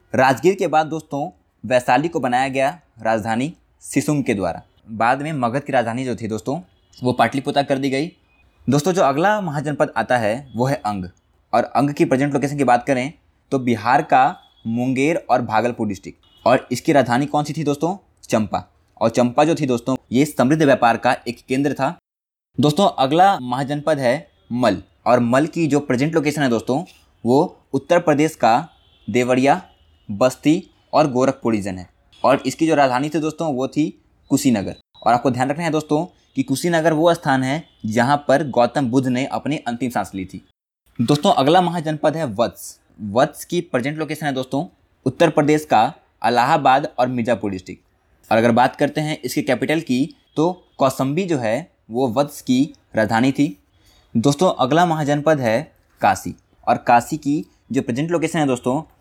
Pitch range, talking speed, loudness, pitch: 120-150 Hz, 175 wpm, -19 LUFS, 135 Hz